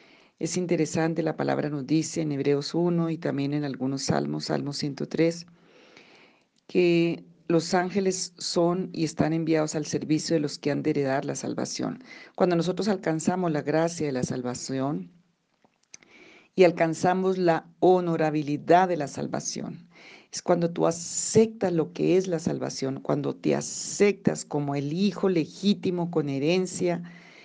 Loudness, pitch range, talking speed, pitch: -26 LUFS, 150-180 Hz, 145 wpm, 165 Hz